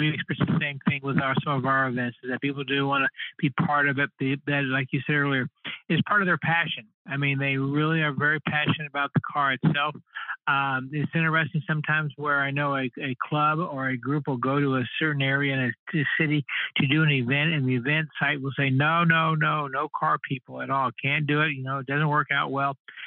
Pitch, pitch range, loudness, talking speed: 145 Hz, 135-155 Hz, -25 LUFS, 245 wpm